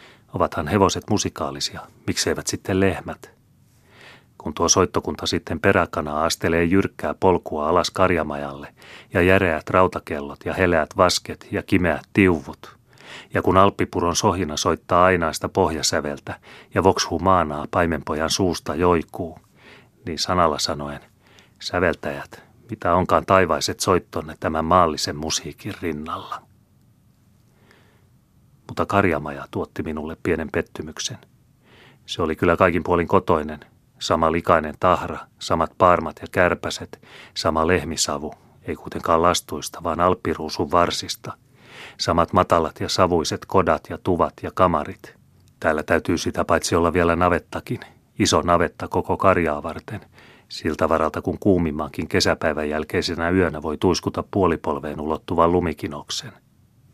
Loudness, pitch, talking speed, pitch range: -21 LUFS, 85 Hz, 115 wpm, 80-95 Hz